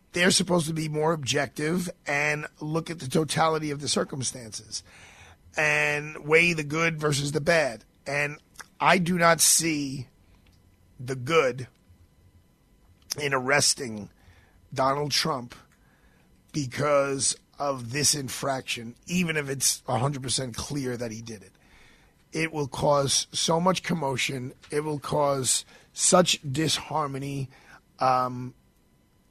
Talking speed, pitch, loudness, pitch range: 120 wpm, 140 Hz, -25 LUFS, 125-155 Hz